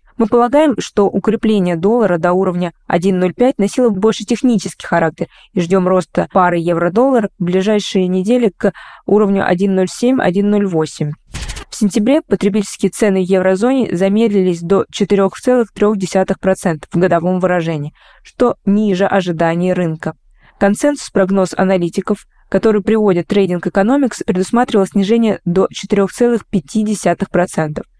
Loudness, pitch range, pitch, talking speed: -14 LUFS, 180-215 Hz, 195 Hz, 105 wpm